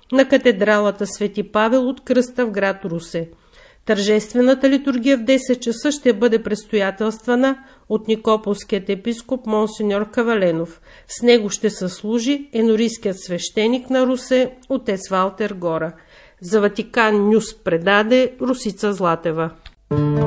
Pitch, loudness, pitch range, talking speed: 220 Hz, -19 LUFS, 200-250 Hz, 120 wpm